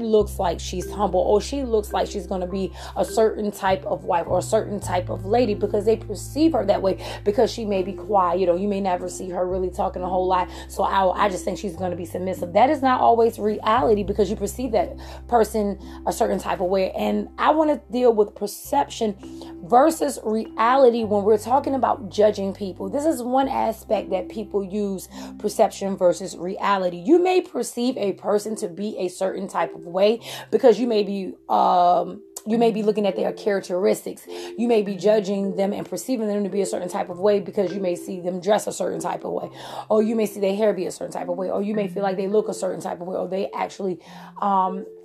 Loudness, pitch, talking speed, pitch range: -22 LUFS, 200 Hz, 230 wpm, 185-220 Hz